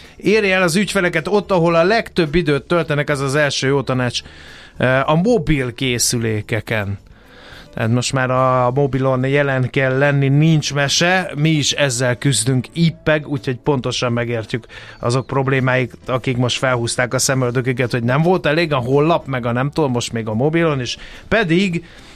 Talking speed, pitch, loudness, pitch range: 160 wpm, 135 Hz, -17 LUFS, 125-155 Hz